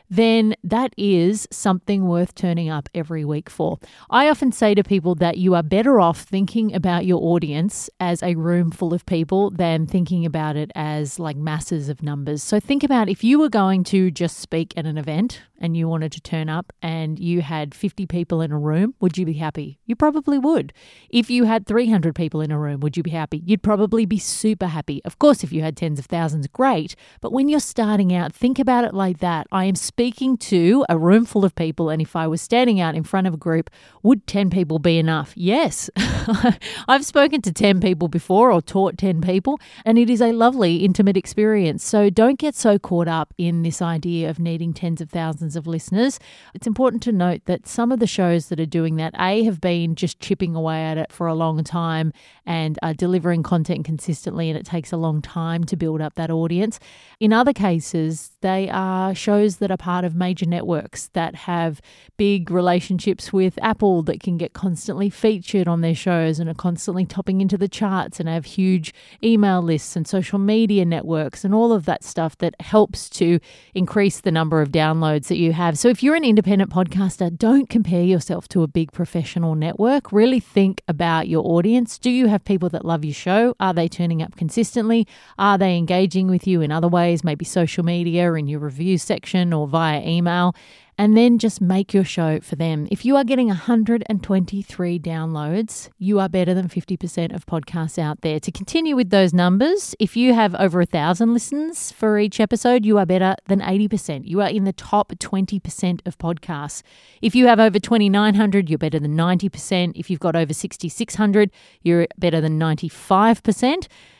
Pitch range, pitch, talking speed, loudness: 165-210 Hz, 180 Hz, 205 wpm, -20 LUFS